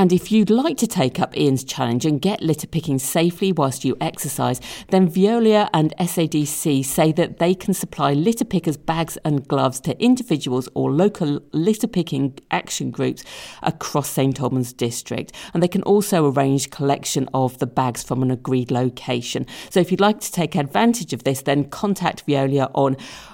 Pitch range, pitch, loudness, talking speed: 135-185 Hz, 155 Hz, -20 LUFS, 175 wpm